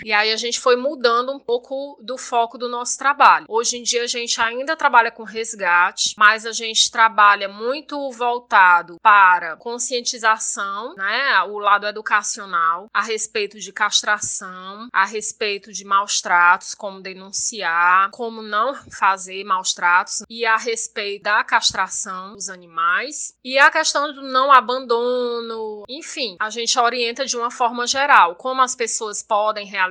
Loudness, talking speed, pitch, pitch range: -18 LUFS, 155 wpm, 225 Hz, 200-245 Hz